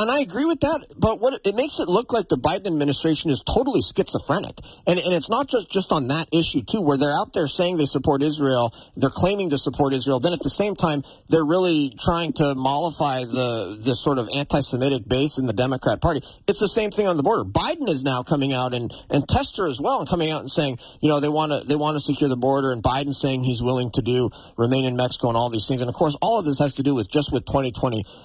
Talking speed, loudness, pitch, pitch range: 255 wpm, -21 LUFS, 145 Hz, 130-170 Hz